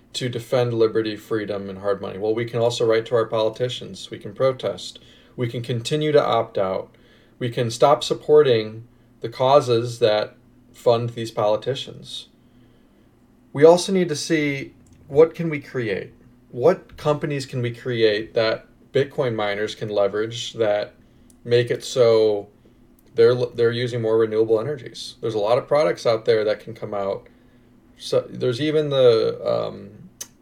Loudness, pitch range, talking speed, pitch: -21 LUFS, 110-135 Hz, 155 wpm, 120 Hz